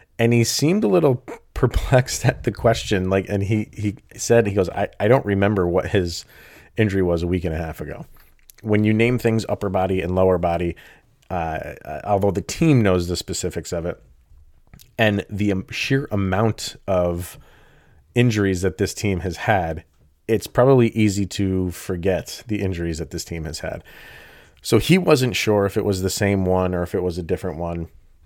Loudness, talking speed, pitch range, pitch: -21 LUFS, 185 wpm, 90-110 Hz, 100 Hz